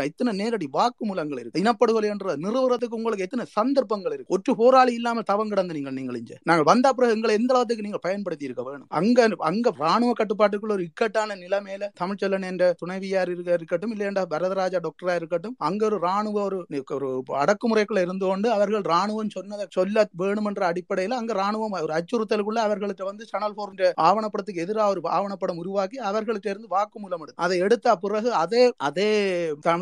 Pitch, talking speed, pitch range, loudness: 205 Hz, 165 wpm, 180-225 Hz, -24 LUFS